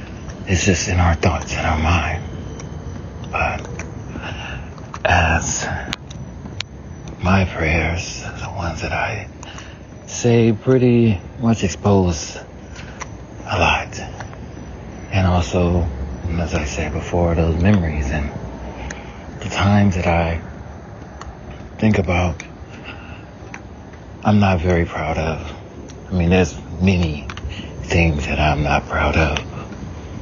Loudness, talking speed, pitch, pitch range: -19 LUFS, 105 wpm, 90 Hz, 80-100 Hz